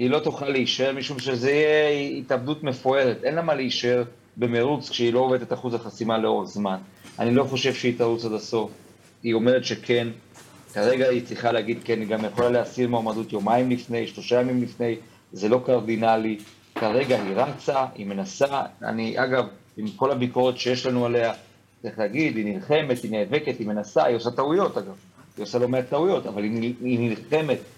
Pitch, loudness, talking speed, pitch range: 120 Hz, -24 LUFS, 180 wpm, 115-130 Hz